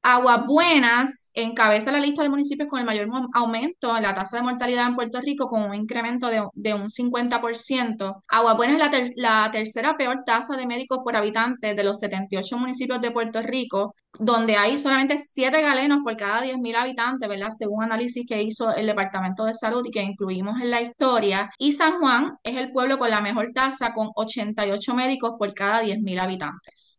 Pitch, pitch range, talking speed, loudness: 235 Hz, 215-255 Hz, 190 wpm, -23 LUFS